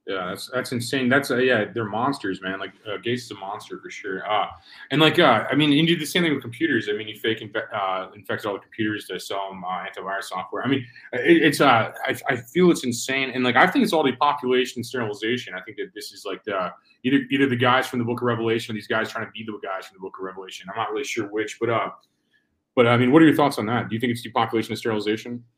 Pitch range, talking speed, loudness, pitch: 110-135 Hz, 275 wpm, -22 LUFS, 120 Hz